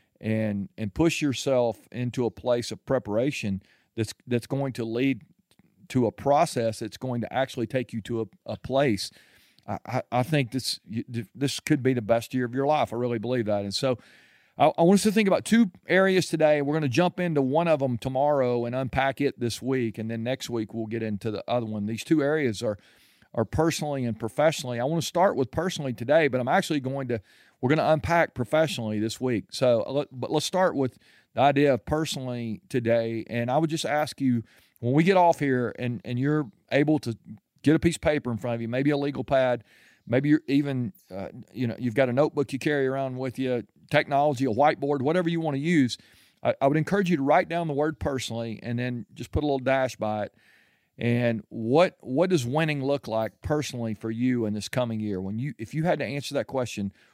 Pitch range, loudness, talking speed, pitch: 115-150 Hz, -26 LUFS, 225 wpm, 130 Hz